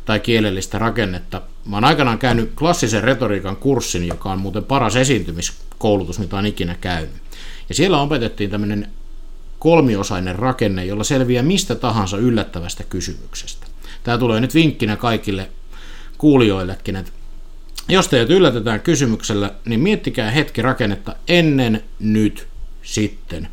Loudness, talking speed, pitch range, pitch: -18 LUFS, 125 wpm, 100-130 Hz, 110 Hz